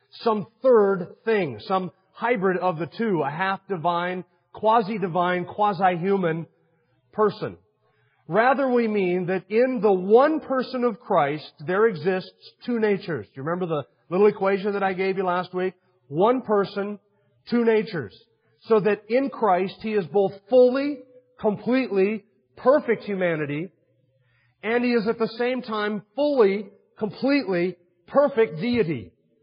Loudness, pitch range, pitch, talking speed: -23 LUFS, 175-225 Hz, 195 Hz, 135 wpm